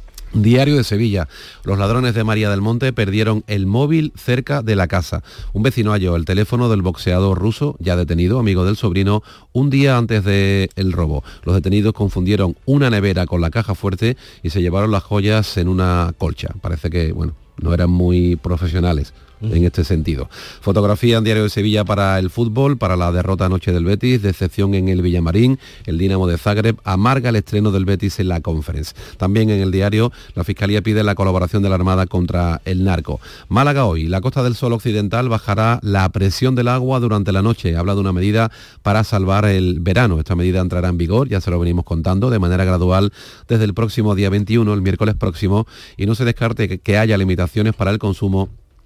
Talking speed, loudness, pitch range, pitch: 200 wpm, -17 LUFS, 90-110 Hz, 100 Hz